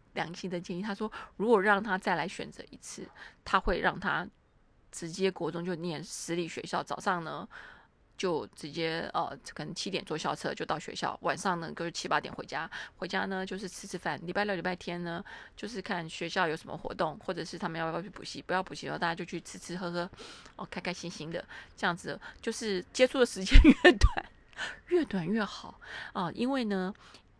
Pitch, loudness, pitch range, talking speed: 185 Hz, -32 LUFS, 170-205 Hz, 300 characters per minute